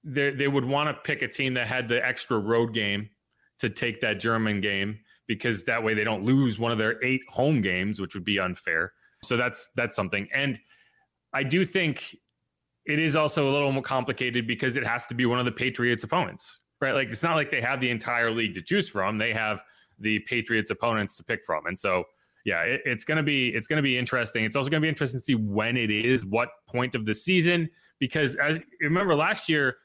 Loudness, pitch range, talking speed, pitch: -26 LUFS, 110-140 Hz, 225 wpm, 125 Hz